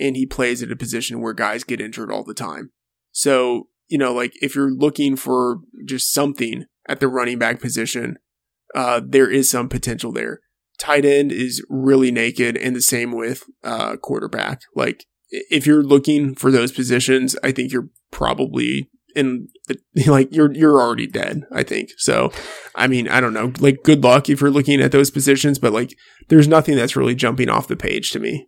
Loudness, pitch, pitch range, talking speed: -18 LUFS, 130 Hz, 120-140 Hz, 195 wpm